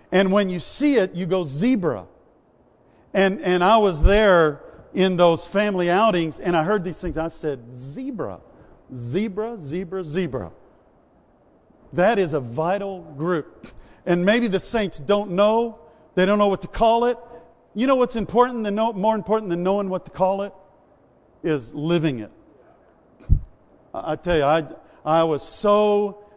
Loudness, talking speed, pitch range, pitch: -21 LUFS, 160 wpm, 165-210 Hz, 190 Hz